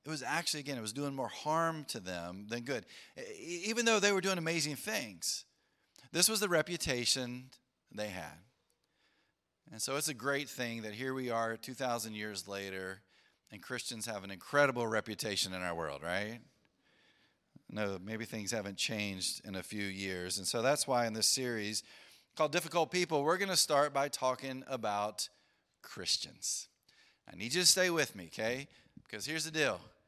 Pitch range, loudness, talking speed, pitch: 105-150 Hz, -35 LUFS, 175 wpm, 120 Hz